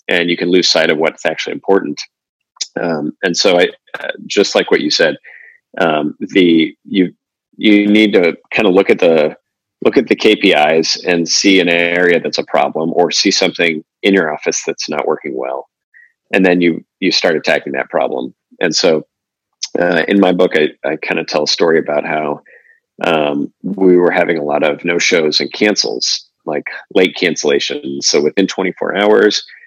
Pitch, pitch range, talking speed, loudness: 90 Hz, 80-100 Hz, 190 wpm, -13 LUFS